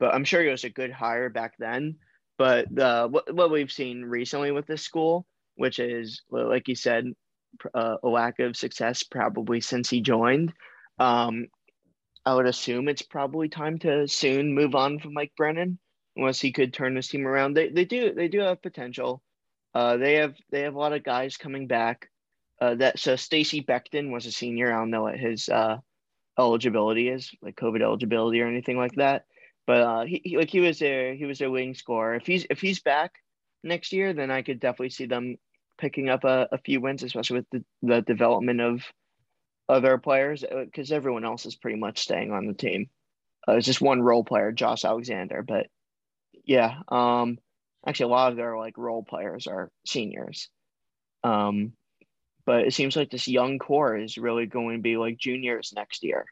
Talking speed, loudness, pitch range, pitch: 195 wpm, -26 LUFS, 120-145 Hz, 130 Hz